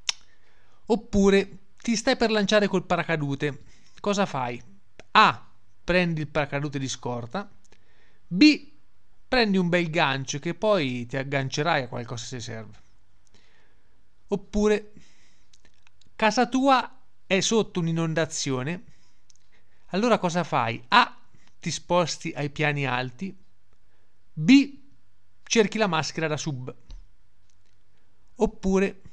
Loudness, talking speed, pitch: -24 LUFS, 105 wpm, 150 Hz